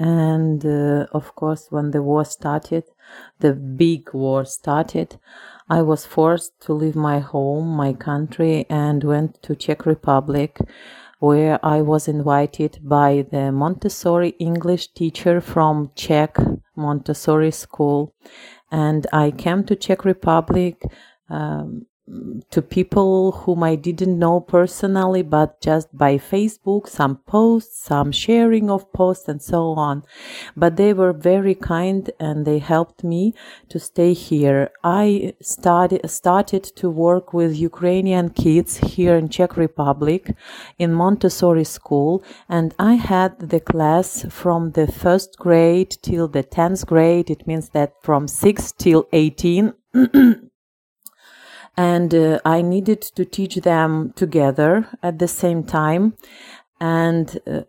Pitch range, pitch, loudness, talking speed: 150-185 Hz, 165 Hz, -18 LUFS, 130 wpm